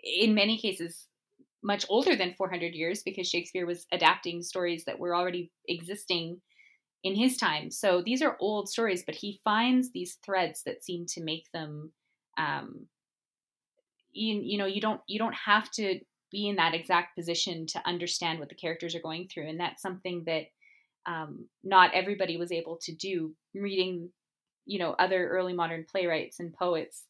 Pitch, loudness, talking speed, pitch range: 180 Hz, -30 LUFS, 175 wpm, 170-205 Hz